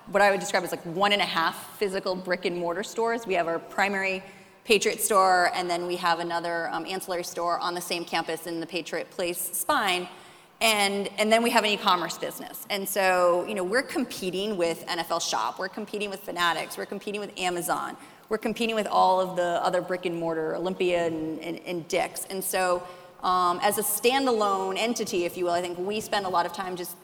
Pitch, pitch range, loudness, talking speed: 185 Hz, 175-205 Hz, -26 LUFS, 205 wpm